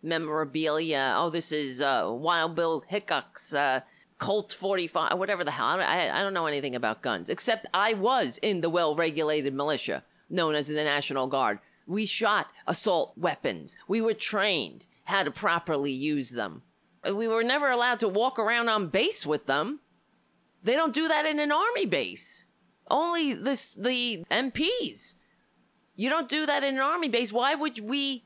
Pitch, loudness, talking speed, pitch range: 200 Hz, -27 LUFS, 170 wpm, 155-260 Hz